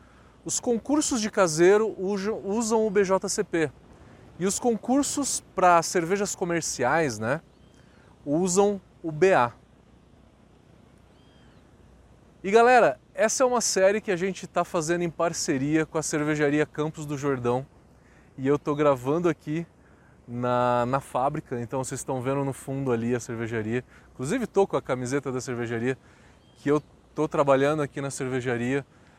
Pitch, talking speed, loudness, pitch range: 155 Hz, 140 wpm, -25 LUFS, 130-190 Hz